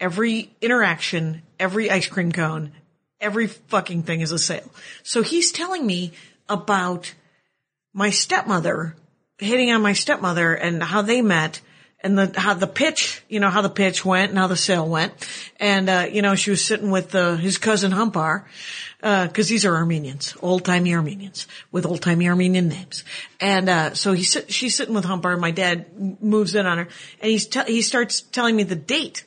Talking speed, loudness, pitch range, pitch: 180 wpm, -20 LUFS, 170-210 Hz, 190 Hz